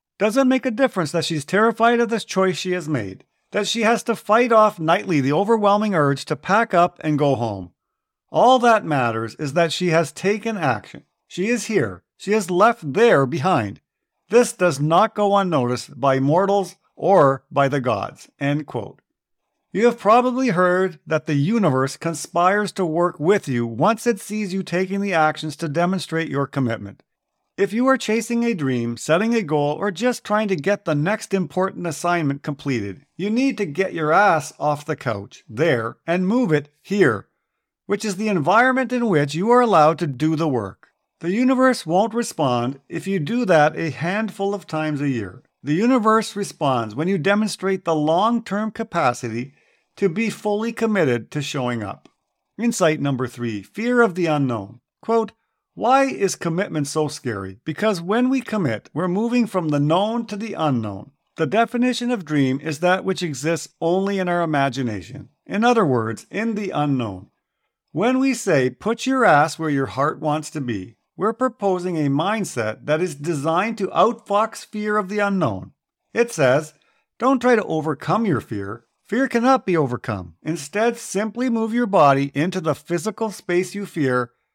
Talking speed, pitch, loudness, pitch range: 175 wpm, 175 Hz, -20 LUFS, 145-215 Hz